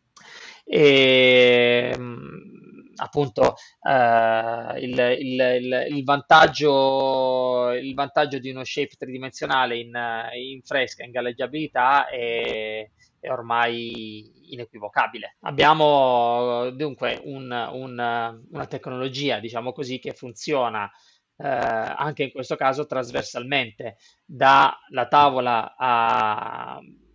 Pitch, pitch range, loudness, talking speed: 125 Hz, 120-135 Hz, -21 LUFS, 95 wpm